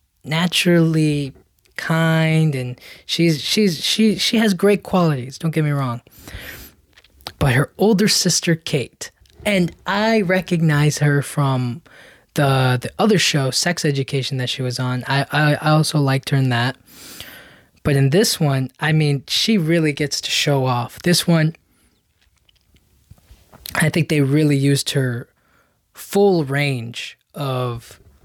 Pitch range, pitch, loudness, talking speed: 130-170 Hz, 145 Hz, -18 LUFS, 140 wpm